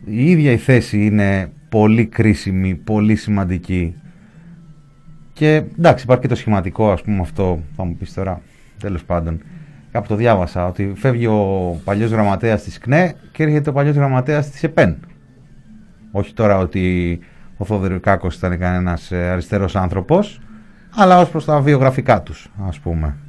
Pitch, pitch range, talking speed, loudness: 105 Hz, 95-145 Hz, 150 wpm, -17 LUFS